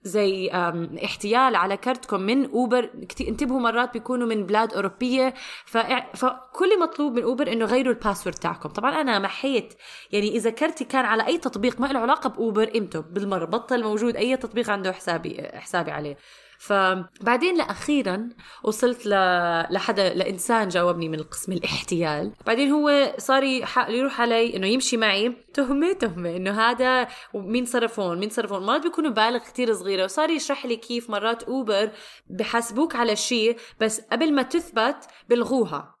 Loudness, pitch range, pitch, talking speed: -24 LUFS, 200-255 Hz, 230 Hz, 150 wpm